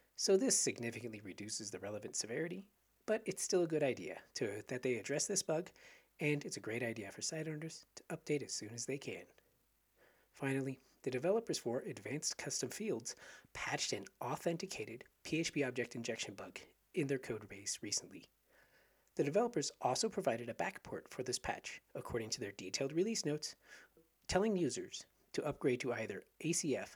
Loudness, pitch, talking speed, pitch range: -40 LUFS, 140 Hz, 165 wpm, 115-165 Hz